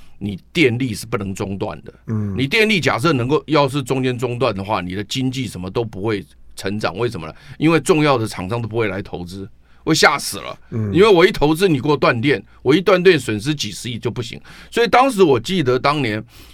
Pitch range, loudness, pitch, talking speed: 105-145 Hz, -18 LUFS, 120 Hz, 320 characters per minute